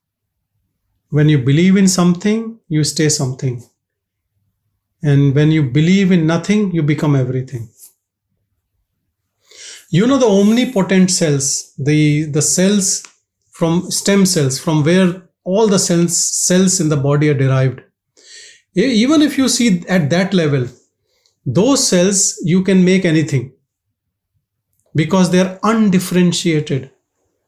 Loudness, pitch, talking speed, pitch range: -14 LUFS, 160 Hz, 120 wpm, 130-190 Hz